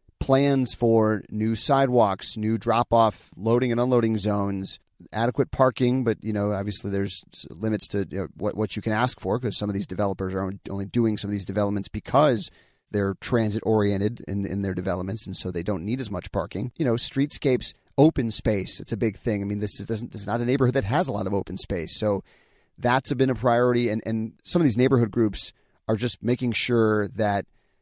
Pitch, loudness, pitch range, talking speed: 110 Hz, -25 LUFS, 100-120 Hz, 205 wpm